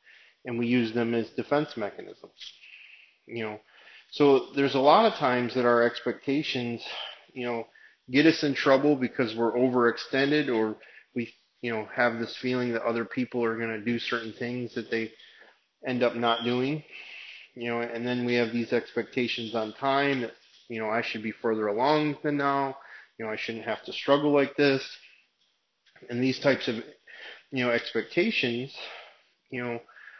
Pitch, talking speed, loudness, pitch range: 120 Hz, 175 wpm, -27 LUFS, 115-135 Hz